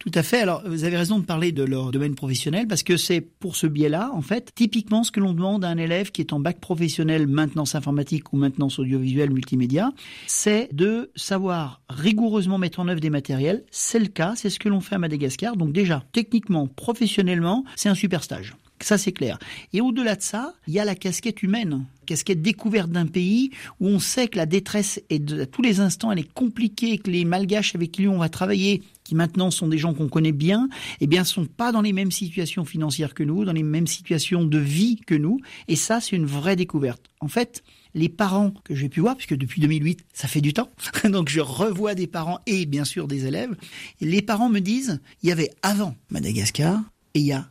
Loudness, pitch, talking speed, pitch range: -23 LUFS, 180 Hz, 230 wpm, 155-205 Hz